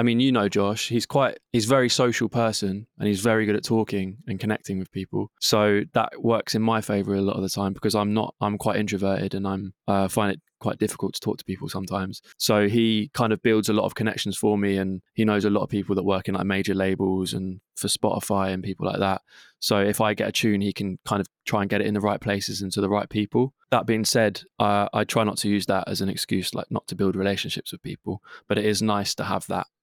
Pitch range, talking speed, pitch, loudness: 95-110 Hz, 265 wpm, 105 Hz, -24 LUFS